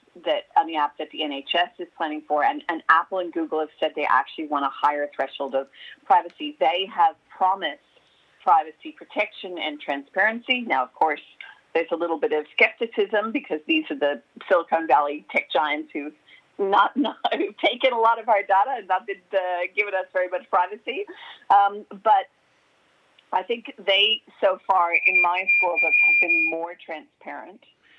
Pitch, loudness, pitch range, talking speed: 185 Hz, -22 LUFS, 160-235 Hz, 180 wpm